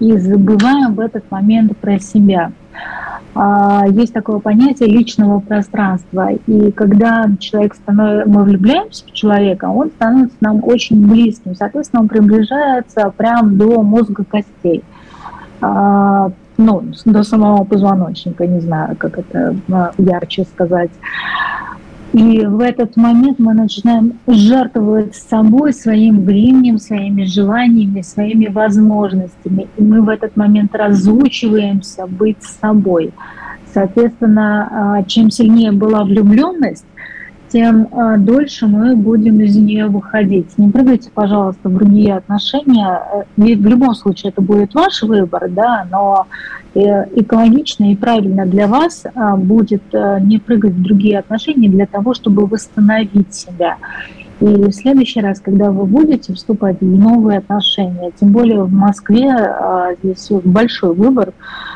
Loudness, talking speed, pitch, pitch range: -12 LUFS, 120 wpm, 210 Hz, 200-230 Hz